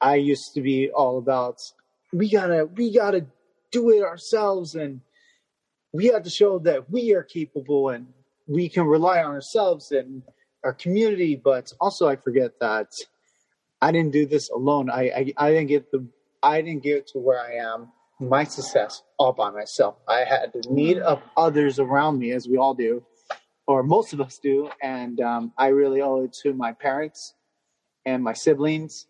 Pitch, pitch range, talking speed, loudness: 145 Hz, 135-165 Hz, 180 wpm, -23 LUFS